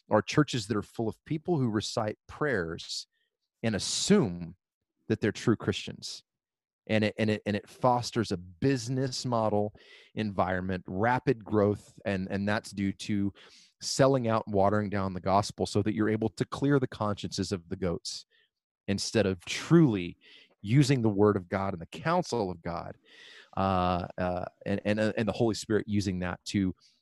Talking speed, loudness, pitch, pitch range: 170 wpm, -30 LUFS, 105 Hz, 95-120 Hz